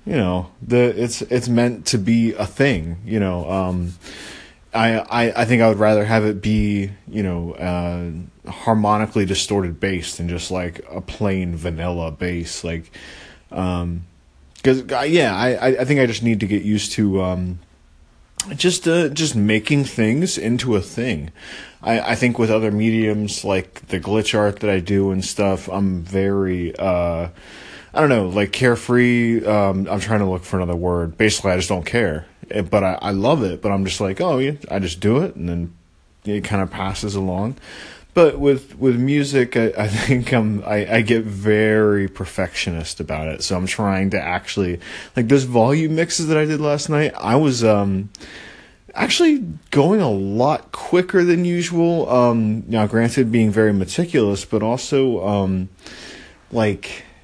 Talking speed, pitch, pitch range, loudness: 175 wpm, 105 Hz, 95-120 Hz, -19 LUFS